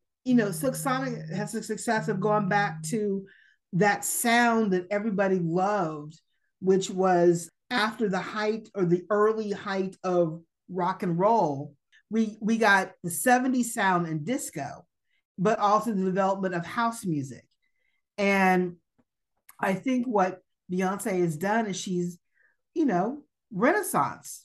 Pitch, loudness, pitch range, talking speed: 200 Hz, -26 LUFS, 180-220 Hz, 135 wpm